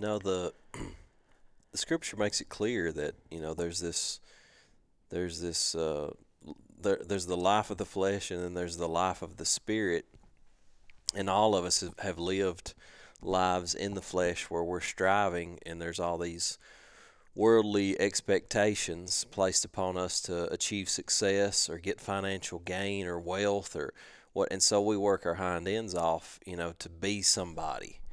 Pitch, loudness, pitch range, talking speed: 95 Hz, -31 LUFS, 85-100 Hz, 165 wpm